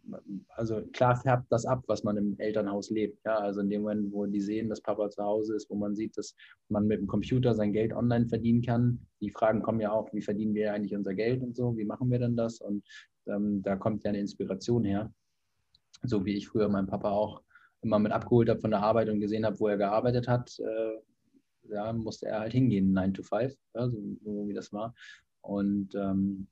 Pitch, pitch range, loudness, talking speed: 105 Hz, 100-115 Hz, -30 LUFS, 230 wpm